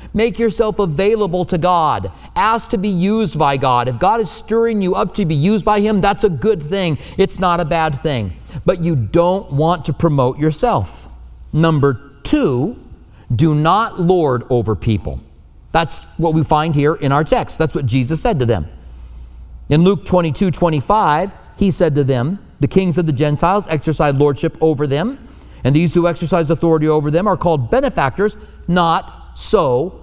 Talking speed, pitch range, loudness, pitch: 175 wpm, 140-190 Hz, -16 LUFS, 165 Hz